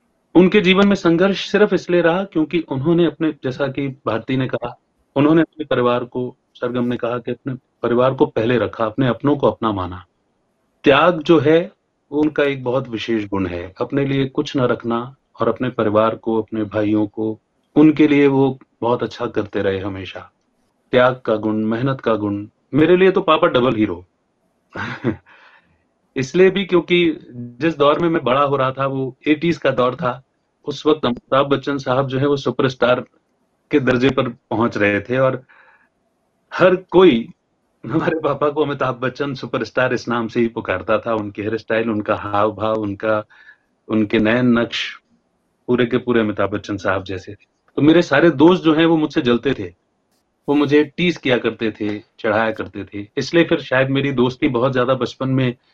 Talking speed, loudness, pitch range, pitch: 180 wpm, -18 LUFS, 110-150 Hz, 130 Hz